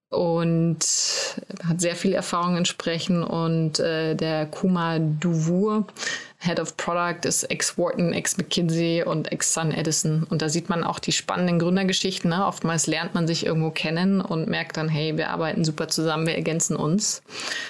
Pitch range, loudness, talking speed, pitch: 160-180 Hz, -24 LUFS, 165 wpm, 165 Hz